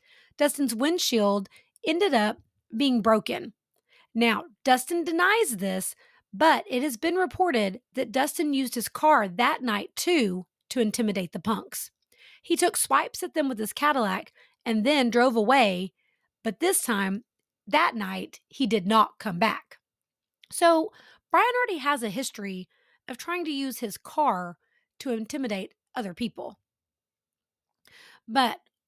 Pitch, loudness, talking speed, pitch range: 255 Hz, -26 LUFS, 135 wpm, 220-320 Hz